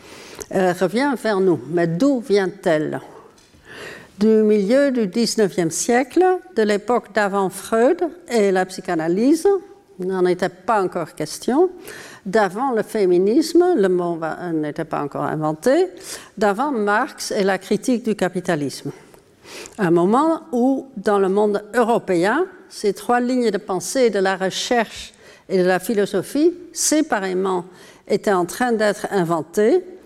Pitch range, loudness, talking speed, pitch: 185-270 Hz, -19 LUFS, 135 wpm, 210 Hz